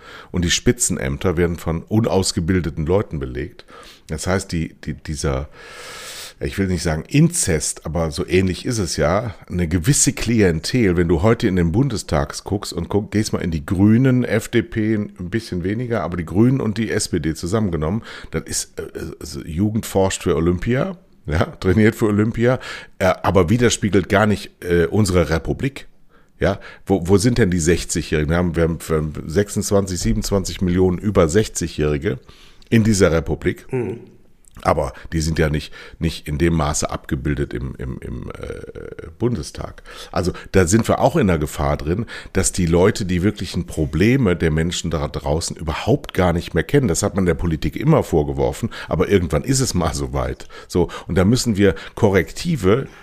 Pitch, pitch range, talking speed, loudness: 90 Hz, 80-110 Hz, 165 wpm, -19 LUFS